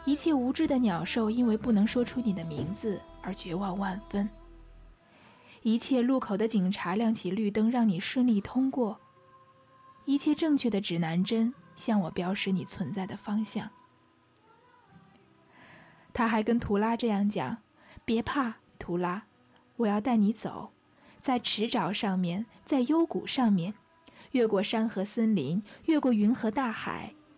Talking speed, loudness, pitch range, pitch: 210 characters per minute, -29 LUFS, 190-245 Hz, 215 Hz